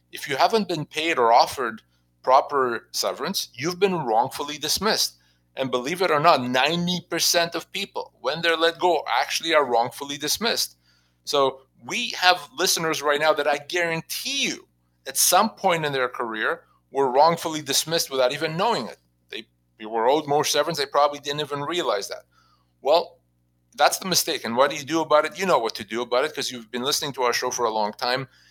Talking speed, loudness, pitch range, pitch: 195 wpm, -23 LUFS, 125-165 Hz, 145 Hz